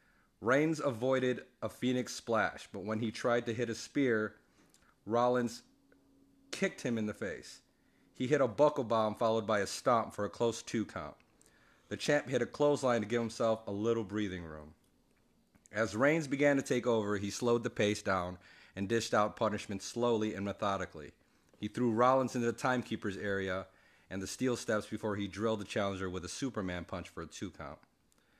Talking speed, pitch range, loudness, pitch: 185 wpm, 100-125 Hz, -34 LUFS, 110 Hz